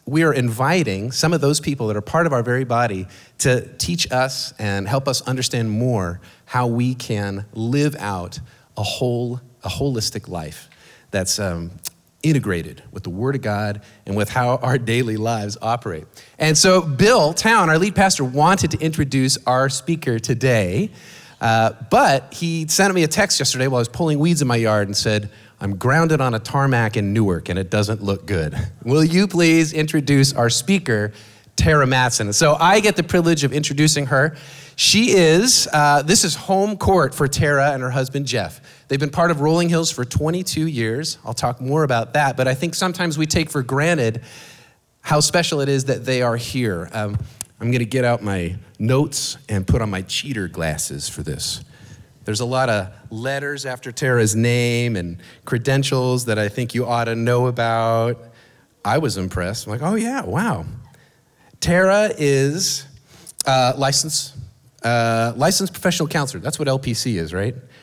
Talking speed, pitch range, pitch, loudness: 180 wpm, 110-150 Hz, 130 Hz, -19 LUFS